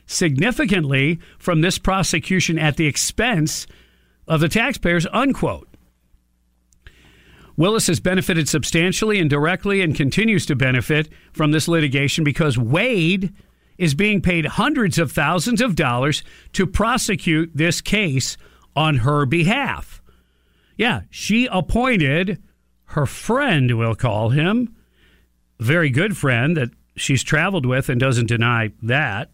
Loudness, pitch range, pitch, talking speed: -19 LUFS, 125-185 Hz, 155 Hz, 125 wpm